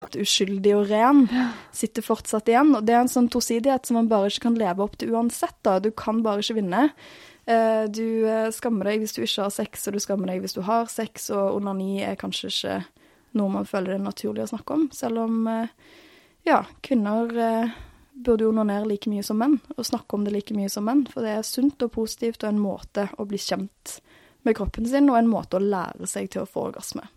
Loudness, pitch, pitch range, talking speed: -24 LUFS, 220 Hz, 205-240 Hz, 220 wpm